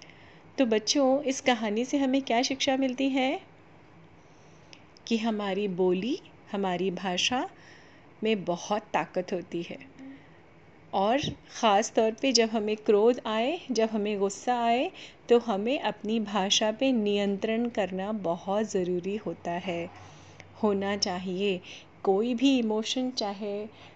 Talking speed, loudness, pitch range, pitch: 125 wpm, -28 LUFS, 195-250 Hz, 215 Hz